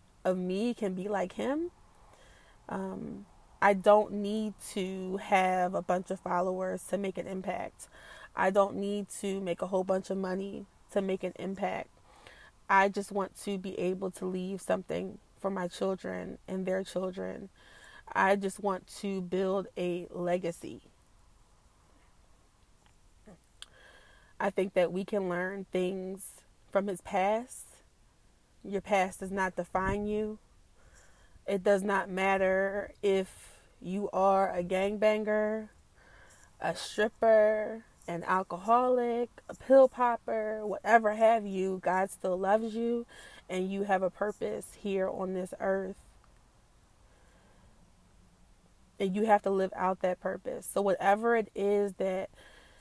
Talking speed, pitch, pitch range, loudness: 135 wpm, 190 Hz, 185-205 Hz, -31 LUFS